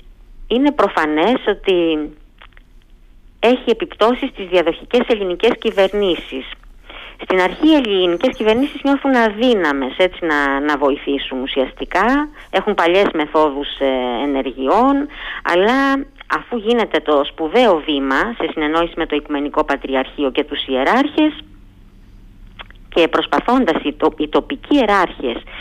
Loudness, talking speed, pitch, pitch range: -16 LUFS, 110 wpm, 170 Hz, 145-235 Hz